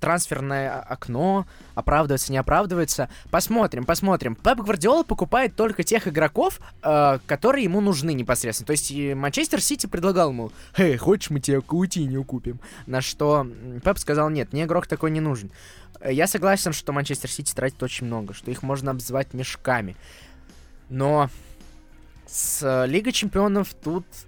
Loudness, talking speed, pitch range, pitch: -23 LUFS, 150 wpm, 125-180 Hz, 145 Hz